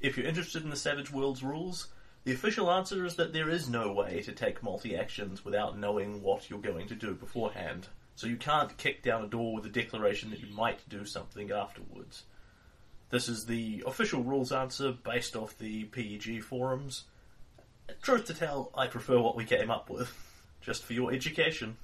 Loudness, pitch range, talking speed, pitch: -34 LUFS, 110-135 Hz, 190 wpm, 125 Hz